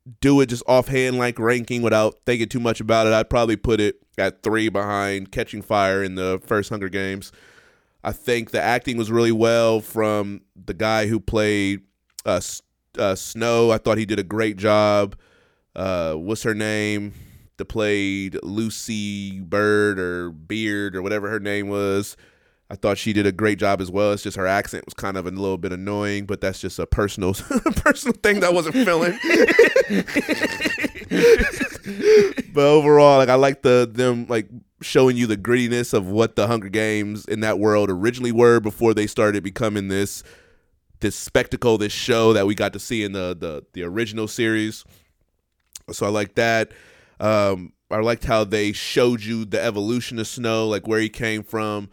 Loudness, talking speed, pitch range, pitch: -20 LUFS, 180 wpm, 100-115 Hz, 110 Hz